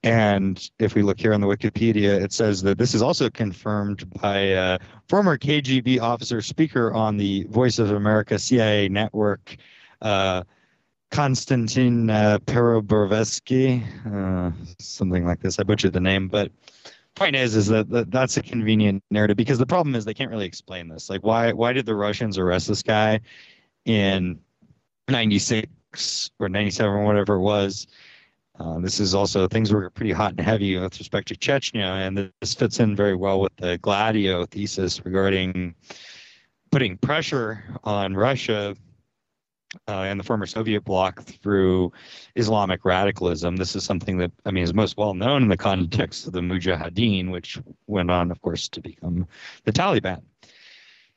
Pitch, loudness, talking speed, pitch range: 105 Hz, -22 LUFS, 165 wpm, 95-115 Hz